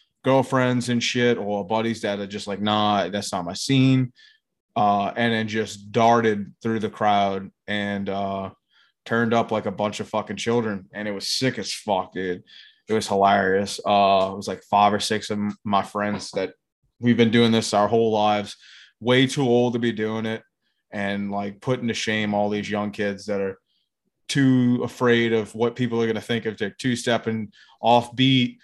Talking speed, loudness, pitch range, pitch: 195 wpm, -23 LUFS, 100-120 Hz, 110 Hz